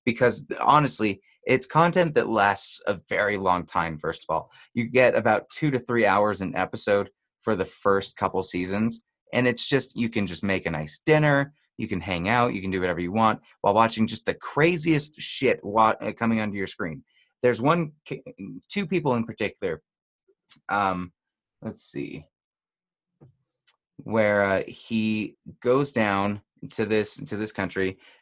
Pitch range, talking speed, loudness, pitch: 100-135 Hz, 165 wpm, -25 LUFS, 110 Hz